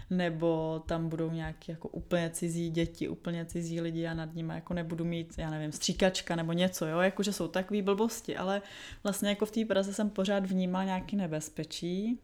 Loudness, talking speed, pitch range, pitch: -33 LUFS, 185 wpm, 165-195 Hz, 175 Hz